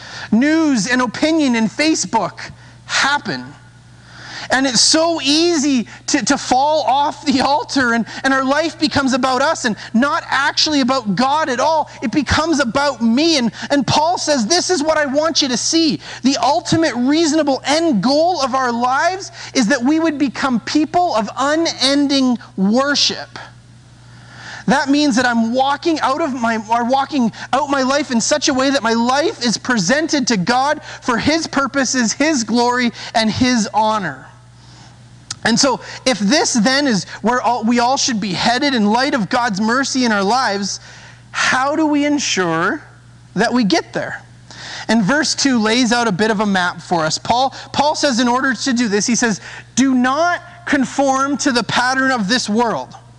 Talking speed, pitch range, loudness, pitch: 175 wpm, 230-290 Hz, -16 LUFS, 260 Hz